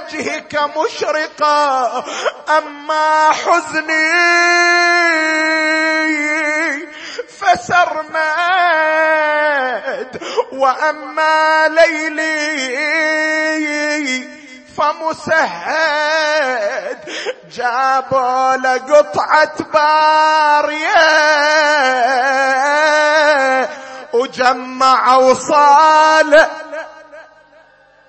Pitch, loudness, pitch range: 310 Hz, -13 LUFS, 295-315 Hz